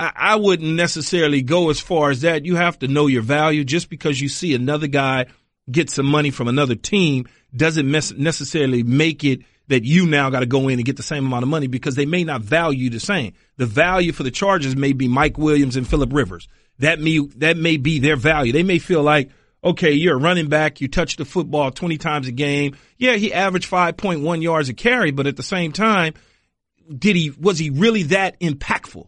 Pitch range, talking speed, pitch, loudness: 135-170 Hz, 220 wpm, 150 Hz, -18 LUFS